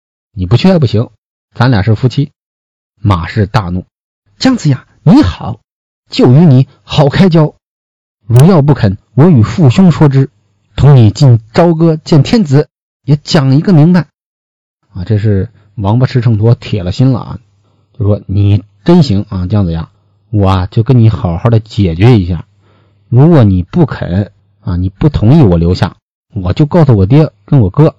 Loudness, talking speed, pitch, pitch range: -9 LUFS, 225 characters per minute, 115 Hz, 100-145 Hz